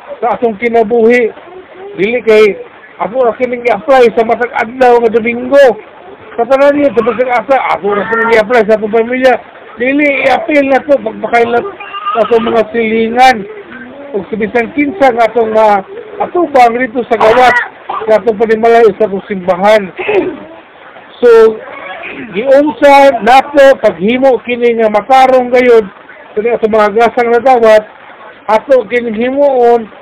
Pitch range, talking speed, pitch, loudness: 225-270 Hz, 135 wpm, 240 Hz, -9 LUFS